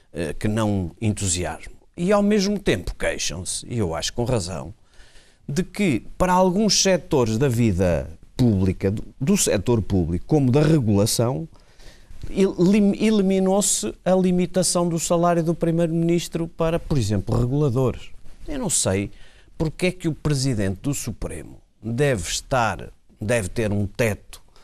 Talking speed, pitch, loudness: 130 wpm, 130 Hz, -22 LUFS